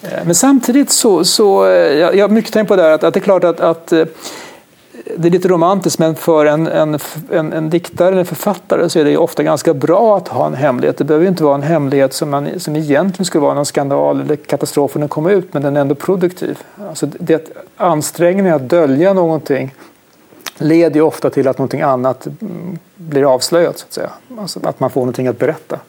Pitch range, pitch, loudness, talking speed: 145-180 Hz, 160 Hz, -13 LUFS, 210 wpm